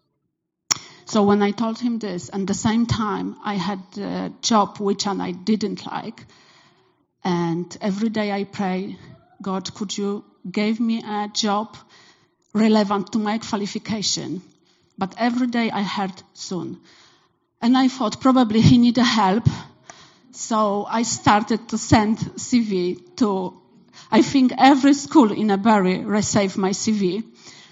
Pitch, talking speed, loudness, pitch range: 210 Hz, 135 wpm, -21 LUFS, 195-225 Hz